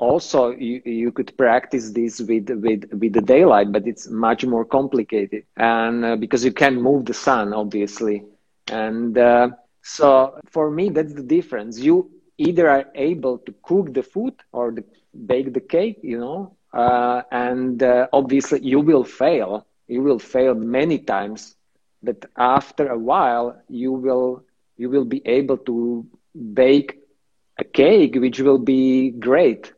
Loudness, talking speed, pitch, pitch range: -19 LUFS, 155 wpm, 125 Hz, 115-135 Hz